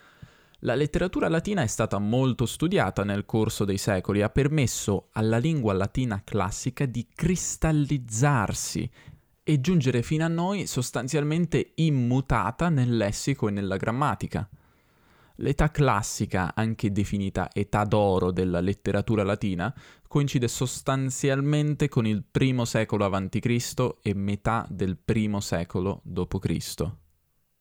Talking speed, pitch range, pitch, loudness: 115 wpm, 100-140 Hz, 115 Hz, -26 LUFS